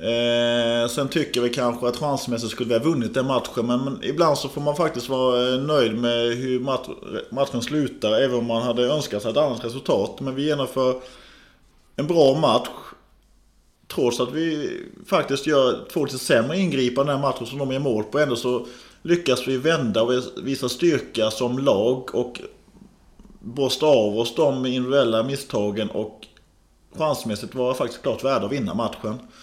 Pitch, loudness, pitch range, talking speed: 125 Hz, -22 LUFS, 120-140 Hz, 170 wpm